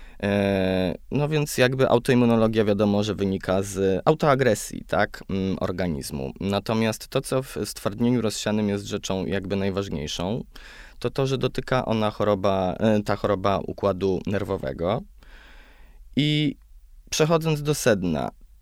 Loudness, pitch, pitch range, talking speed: -24 LUFS, 105 Hz, 95-120 Hz, 115 wpm